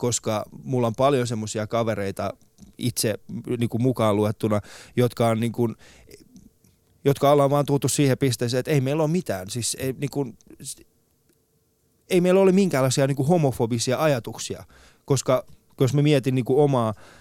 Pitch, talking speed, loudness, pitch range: 130 Hz, 155 wpm, -23 LUFS, 115-140 Hz